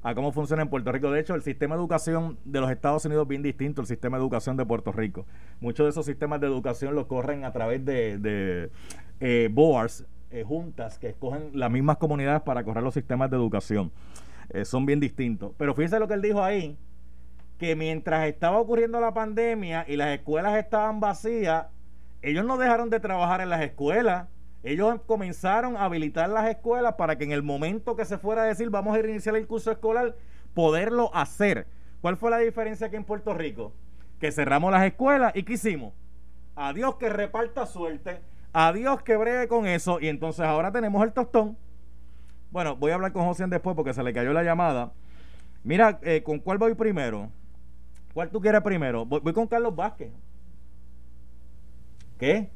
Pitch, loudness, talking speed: 155 Hz, -26 LUFS, 190 wpm